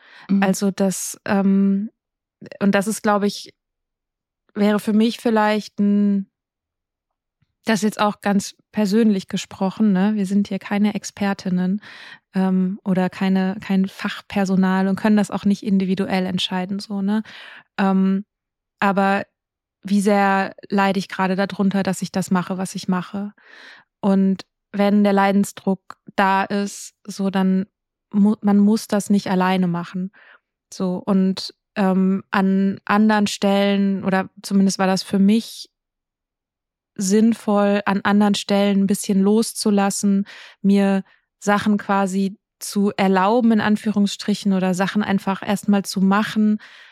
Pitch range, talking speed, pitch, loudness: 195-205 Hz, 130 wpm, 200 Hz, -20 LUFS